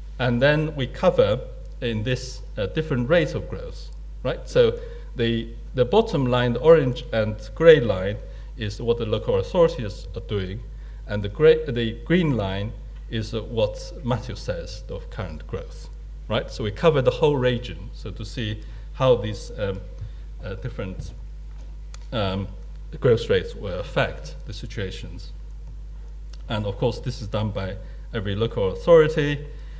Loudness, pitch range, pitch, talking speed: -23 LUFS, 105-145 Hz, 120 Hz, 150 wpm